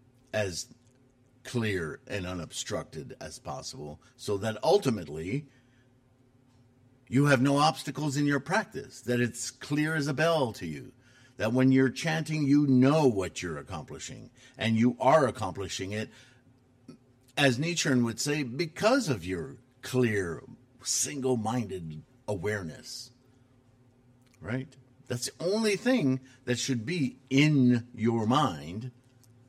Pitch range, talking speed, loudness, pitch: 120-130 Hz, 120 wpm, -29 LUFS, 130 Hz